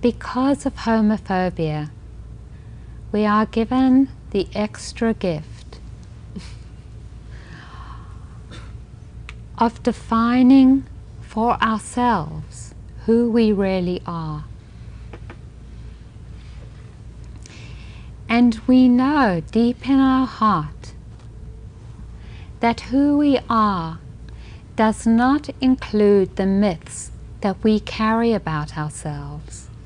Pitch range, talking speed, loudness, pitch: 150-240 Hz, 75 wpm, -19 LUFS, 210 Hz